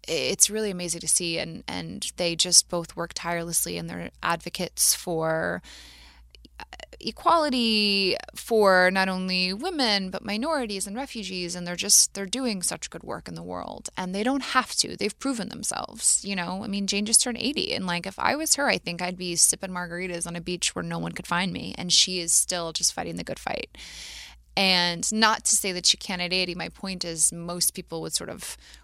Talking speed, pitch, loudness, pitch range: 205 wpm, 185 Hz, -24 LUFS, 170-210 Hz